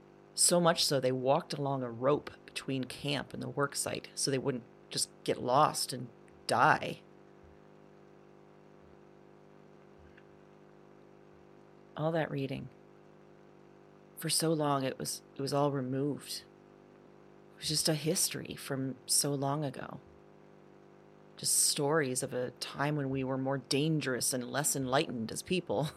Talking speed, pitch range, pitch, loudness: 135 wpm, 135-160 Hz, 140 Hz, -32 LUFS